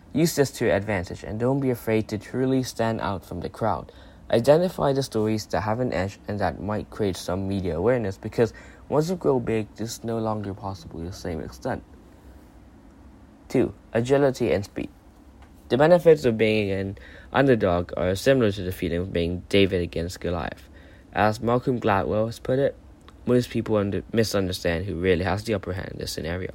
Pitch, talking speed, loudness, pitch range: 105 Hz, 190 wpm, -25 LUFS, 90-115 Hz